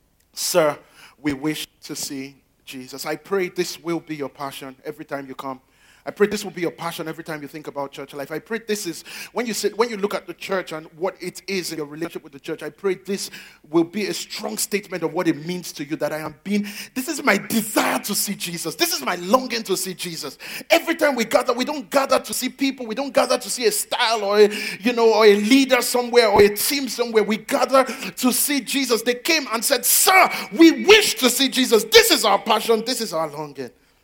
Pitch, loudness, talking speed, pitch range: 205 Hz, -20 LUFS, 245 wpm, 160-250 Hz